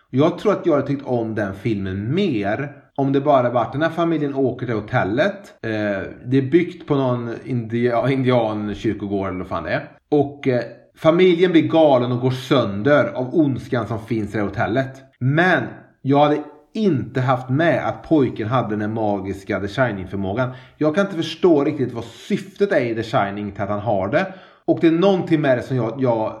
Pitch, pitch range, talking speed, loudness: 130 Hz, 110-150 Hz, 200 wpm, -20 LUFS